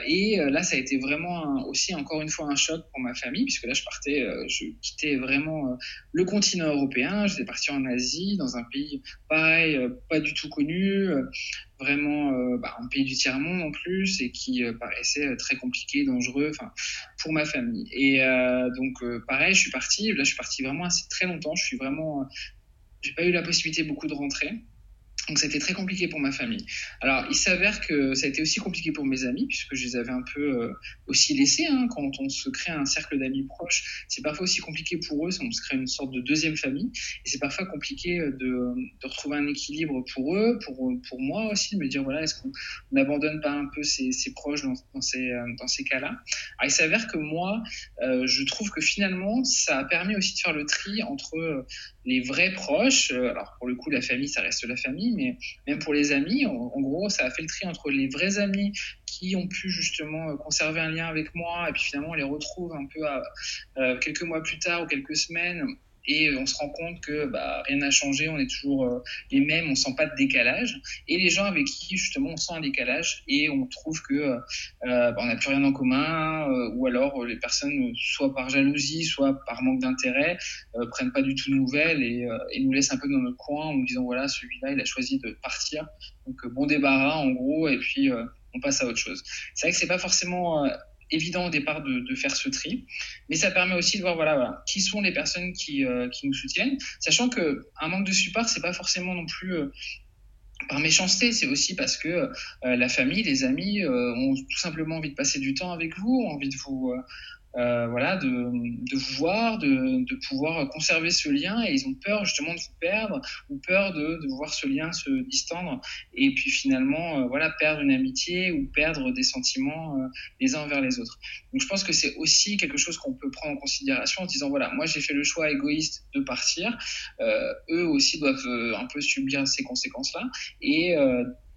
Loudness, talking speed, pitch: -26 LUFS, 225 wpm, 170 Hz